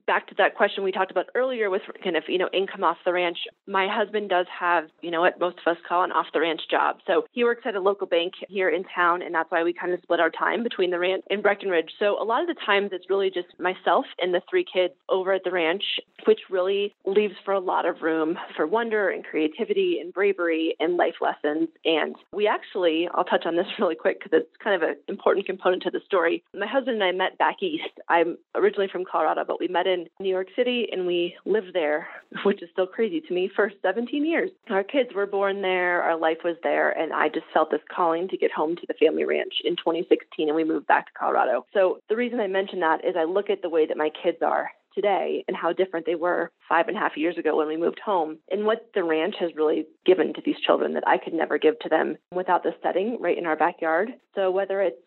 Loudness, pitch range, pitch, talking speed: -25 LUFS, 170-210 Hz, 185 Hz, 255 wpm